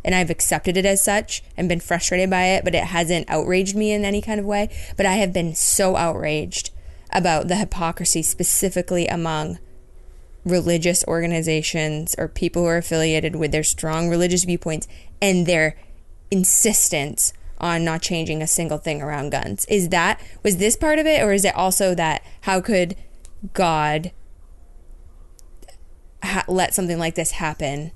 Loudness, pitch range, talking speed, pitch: -20 LUFS, 155-185 Hz, 165 wpm, 170 Hz